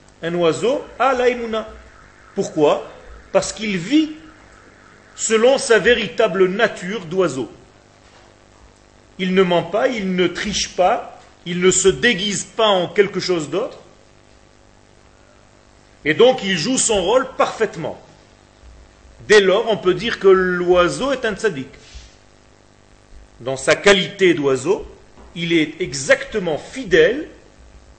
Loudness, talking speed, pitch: -17 LUFS, 120 wpm, 185 Hz